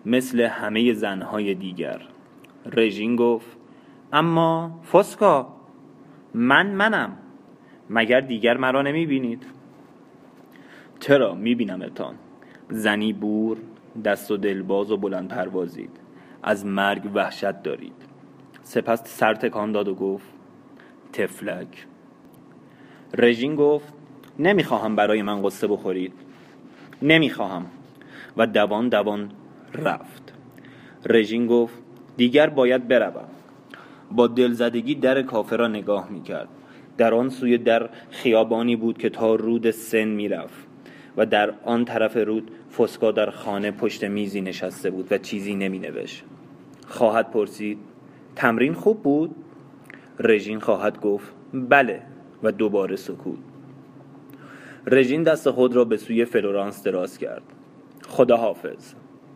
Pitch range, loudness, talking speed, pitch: 105-135 Hz, -22 LUFS, 110 wpm, 115 Hz